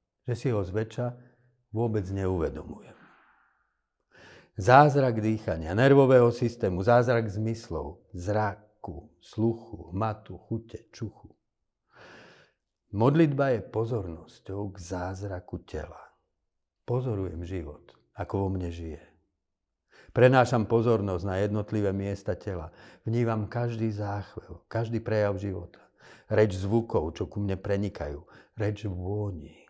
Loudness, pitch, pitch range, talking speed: -28 LUFS, 105 Hz, 95-115 Hz, 100 wpm